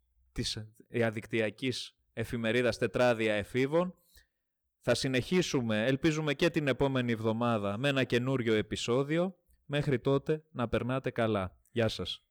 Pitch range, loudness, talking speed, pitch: 110-140 Hz, -31 LUFS, 110 wpm, 120 Hz